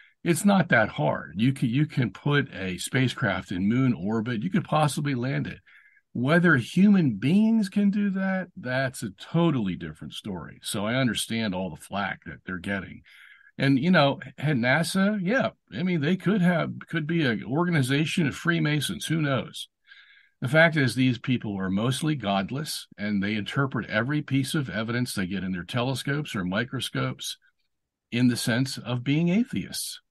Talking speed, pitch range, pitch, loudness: 170 wpm, 115-170 Hz, 135 Hz, -26 LUFS